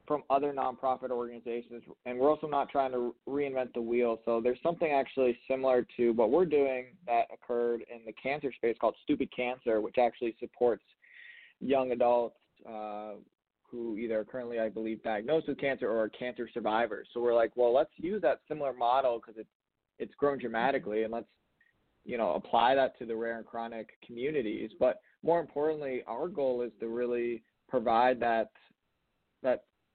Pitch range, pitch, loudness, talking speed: 115-135 Hz, 120 Hz, -32 LUFS, 170 wpm